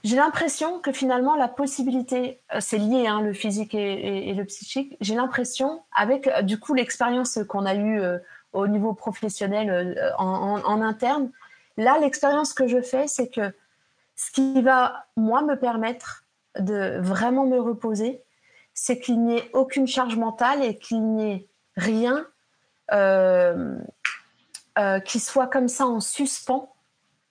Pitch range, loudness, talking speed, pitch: 210-265 Hz, -24 LUFS, 155 wpm, 240 Hz